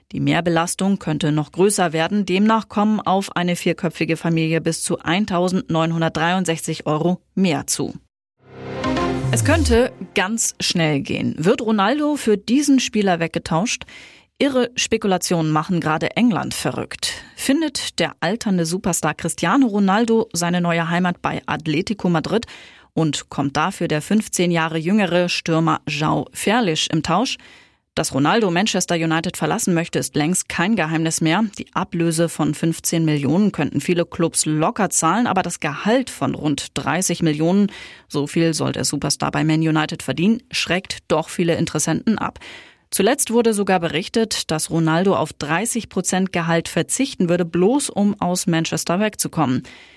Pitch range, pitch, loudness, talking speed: 160-205 Hz, 175 Hz, -19 LUFS, 140 wpm